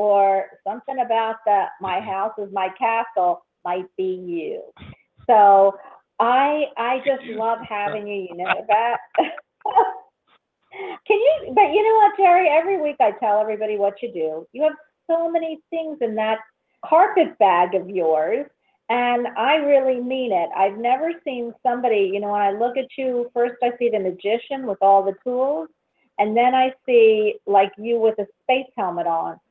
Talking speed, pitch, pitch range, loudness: 170 wpm, 240 Hz, 205-310 Hz, -20 LUFS